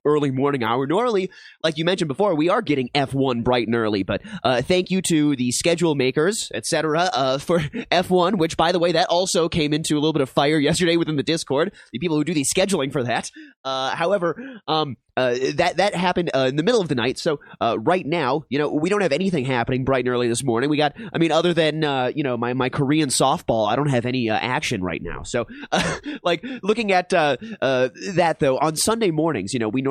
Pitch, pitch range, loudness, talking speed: 150 Hz, 130-175 Hz, -21 LUFS, 240 wpm